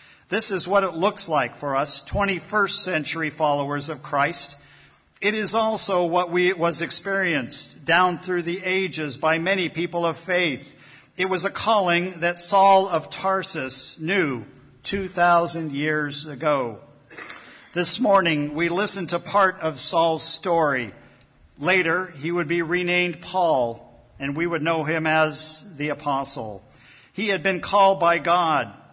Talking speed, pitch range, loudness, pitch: 145 wpm, 155-190 Hz, -21 LUFS, 170 Hz